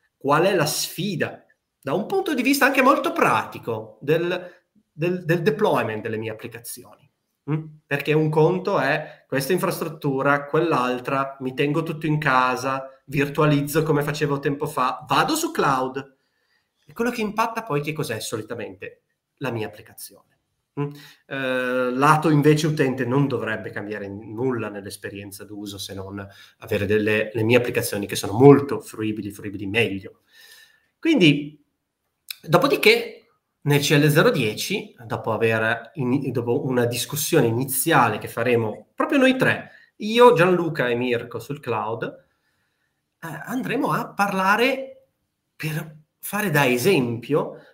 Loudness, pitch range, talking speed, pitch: -22 LUFS, 120-165 Hz, 130 wpm, 145 Hz